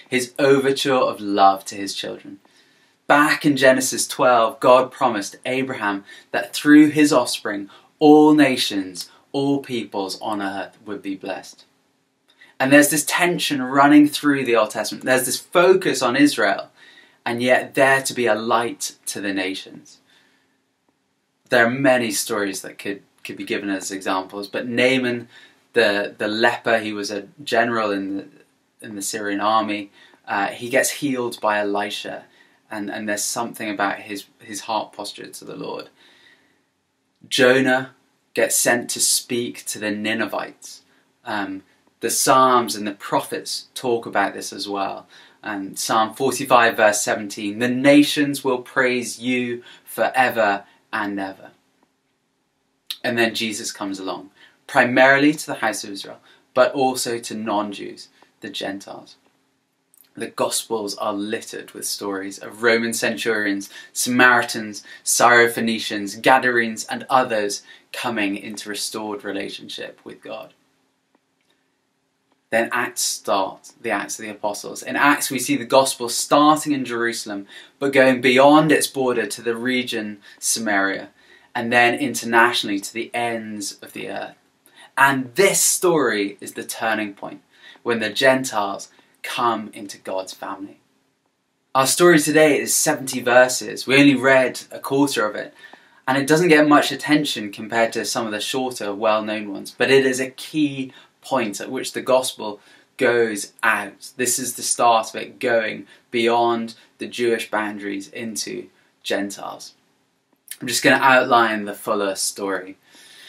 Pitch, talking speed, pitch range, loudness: 120 Hz, 145 wpm, 105-135 Hz, -19 LUFS